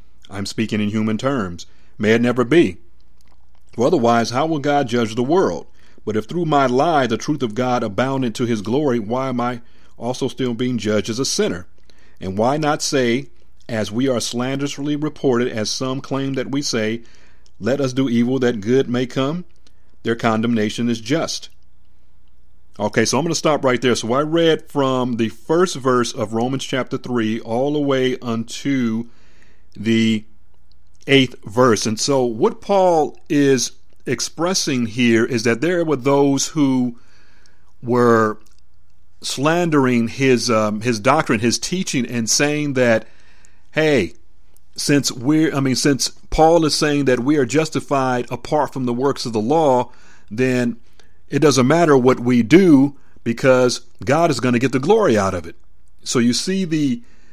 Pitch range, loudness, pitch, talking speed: 110-140 Hz, -18 LUFS, 125 Hz, 165 wpm